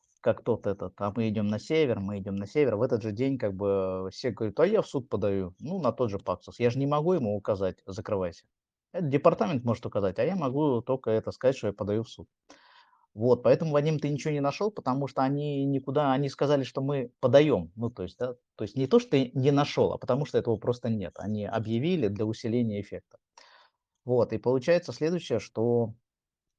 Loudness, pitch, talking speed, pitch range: -28 LUFS, 125 Hz, 215 wpm, 110-145 Hz